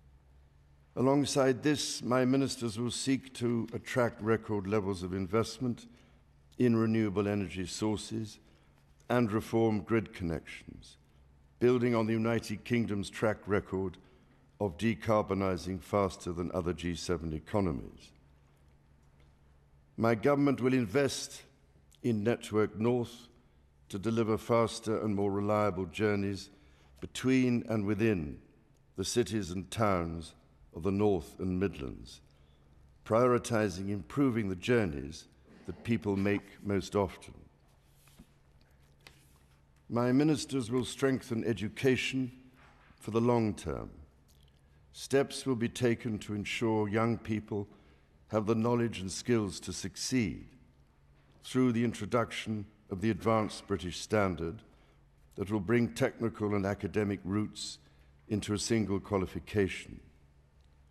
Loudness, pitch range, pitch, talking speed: -32 LUFS, 80-115 Hz, 105 Hz, 110 wpm